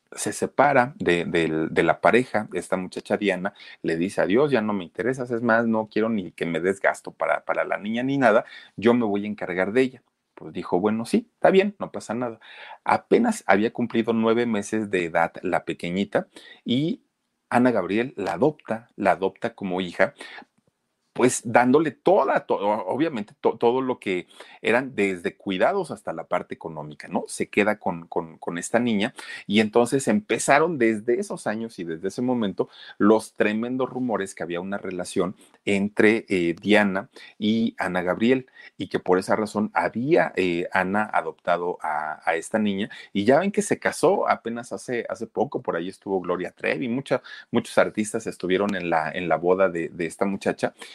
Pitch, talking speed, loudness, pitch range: 105 Hz, 180 wpm, -24 LUFS, 90-115 Hz